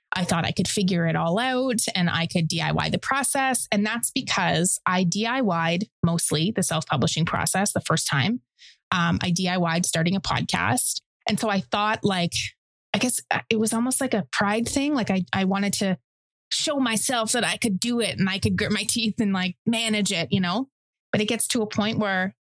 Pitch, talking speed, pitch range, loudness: 200 Hz, 210 wpm, 175-230 Hz, -23 LUFS